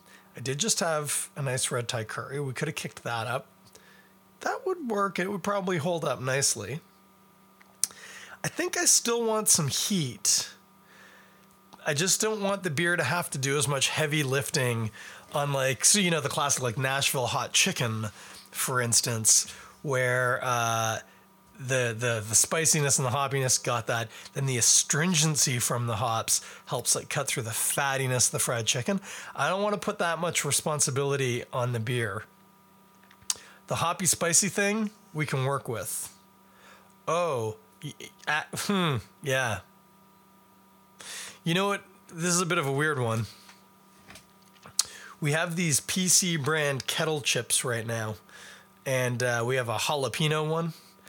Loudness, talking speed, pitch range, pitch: -26 LUFS, 160 wpm, 120-170 Hz, 140 Hz